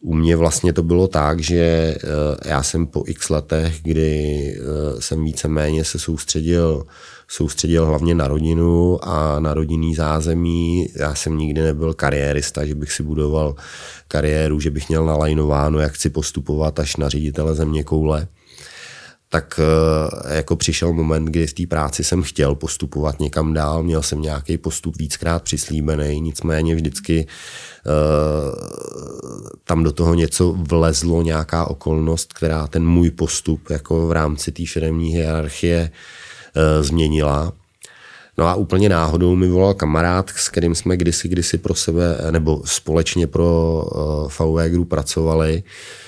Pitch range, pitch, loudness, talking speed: 75-85 Hz, 80 Hz, -19 LUFS, 140 wpm